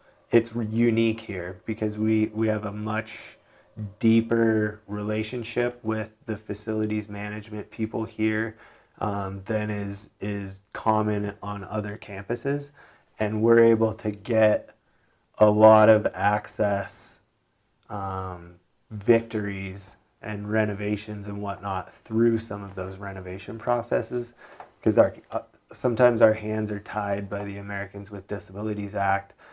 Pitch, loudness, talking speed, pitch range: 105 Hz, -26 LUFS, 120 wpm, 100-110 Hz